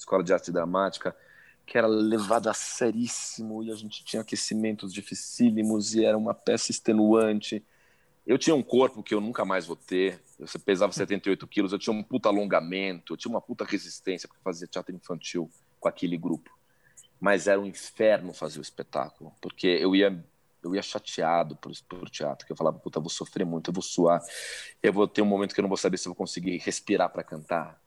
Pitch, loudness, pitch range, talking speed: 100 Hz, -28 LUFS, 95-110 Hz, 205 wpm